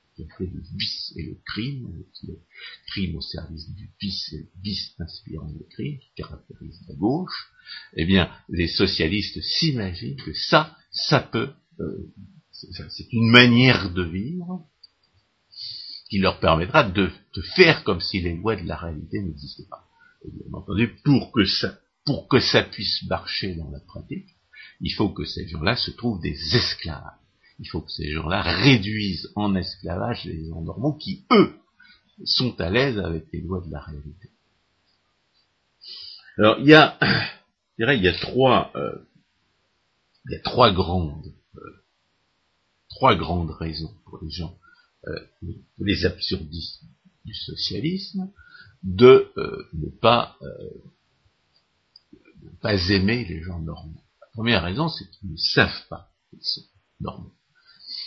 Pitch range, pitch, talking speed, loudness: 85-115 Hz, 95 Hz, 155 wpm, -22 LUFS